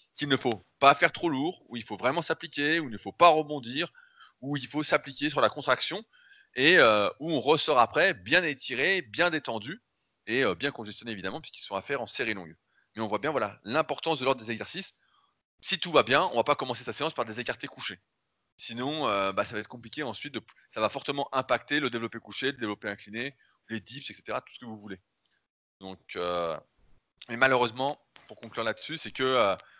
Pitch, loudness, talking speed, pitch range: 130 Hz, -28 LUFS, 220 wpm, 110-150 Hz